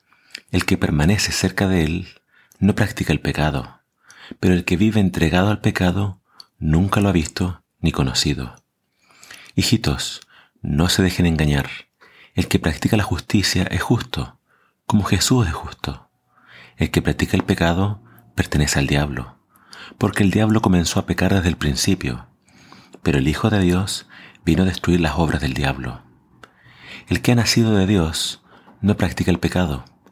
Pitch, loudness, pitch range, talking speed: 90 Hz, -20 LUFS, 80-100 Hz, 155 wpm